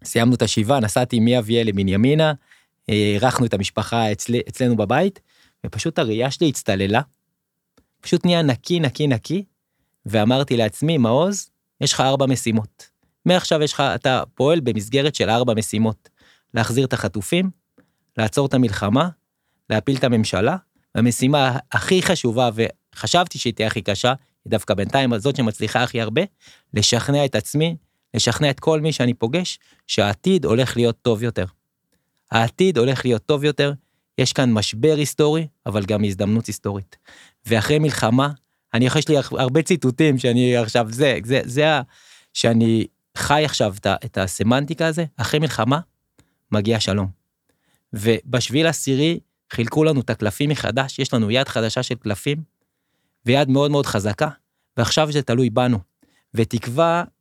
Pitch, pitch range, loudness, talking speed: 125 Hz, 110-145 Hz, -20 LUFS, 140 wpm